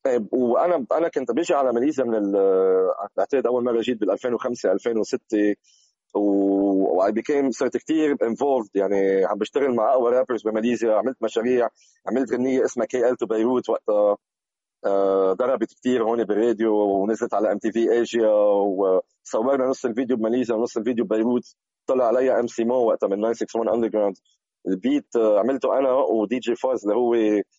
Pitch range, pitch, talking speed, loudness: 100-125 Hz, 115 Hz, 155 wpm, -22 LUFS